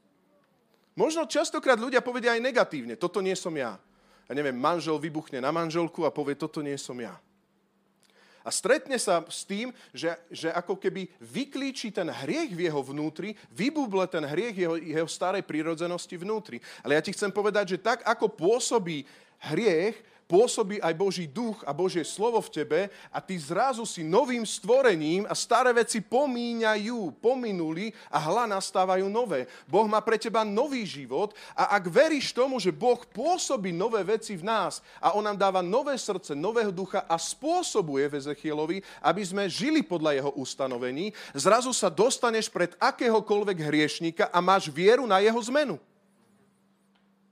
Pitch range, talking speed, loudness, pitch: 165-235 Hz, 160 wpm, -27 LUFS, 200 Hz